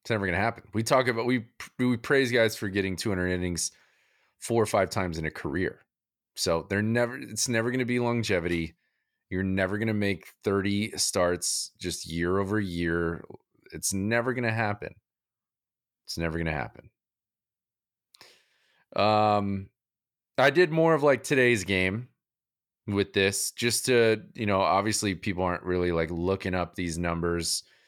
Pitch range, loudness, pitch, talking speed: 90-115 Hz, -27 LUFS, 100 Hz, 165 wpm